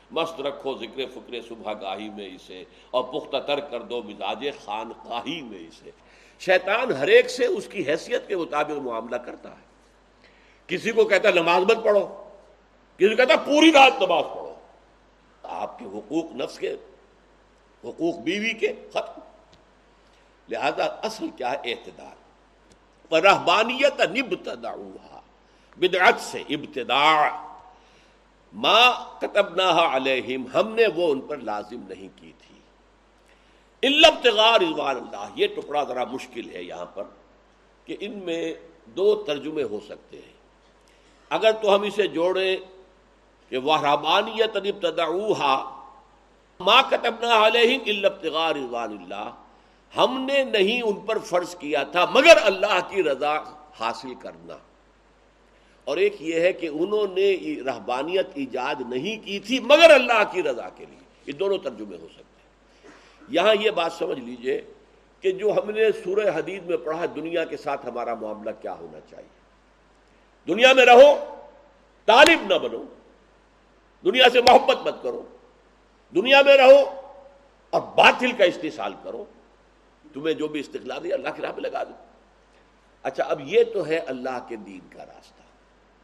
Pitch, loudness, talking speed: 210 Hz, -21 LUFS, 145 wpm